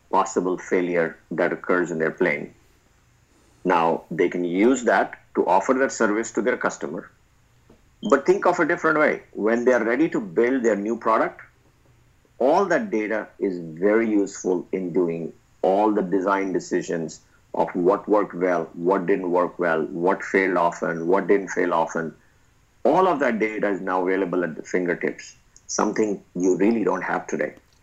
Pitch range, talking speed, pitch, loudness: 90-125 Hz, 165 wpm, 105 Hz, -22 LUFS